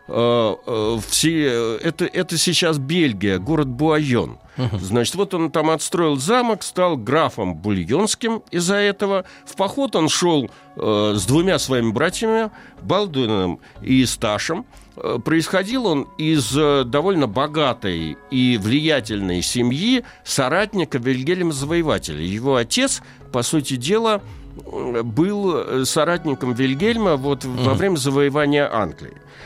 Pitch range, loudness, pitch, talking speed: 120-175 Hz, -20 LUFS, 145 Hz, 100 wpm